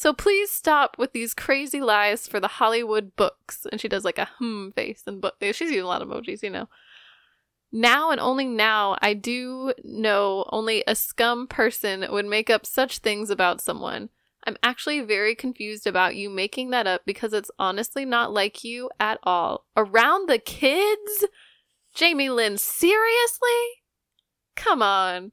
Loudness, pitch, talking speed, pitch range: -23 LUFS, 235 Hz, 170 wpm, 210-275 Hz